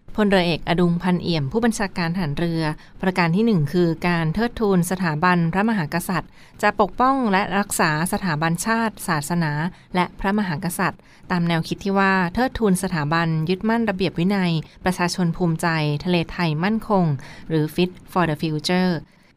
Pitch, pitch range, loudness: 180 Hz, 165-195 Hz, -21 LUFS